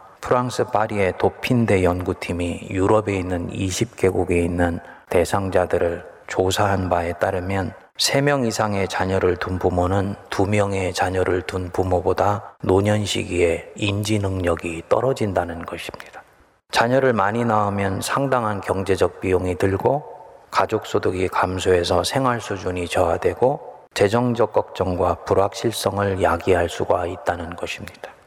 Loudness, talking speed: -21 LUFS, 290 characters per minute